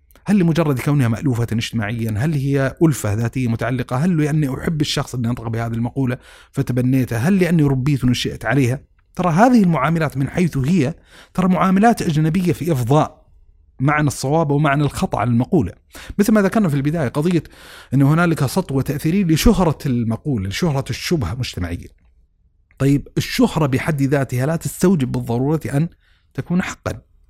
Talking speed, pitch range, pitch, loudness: 150 wpm, 120-165 Hz, 140 Hz, -18 LUFS